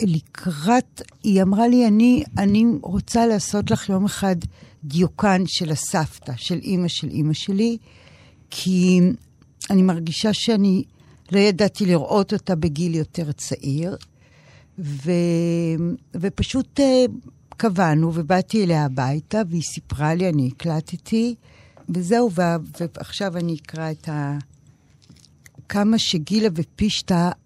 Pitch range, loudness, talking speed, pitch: 160-205 Hz, -21 LUFS, 110 wpm, 180 Hz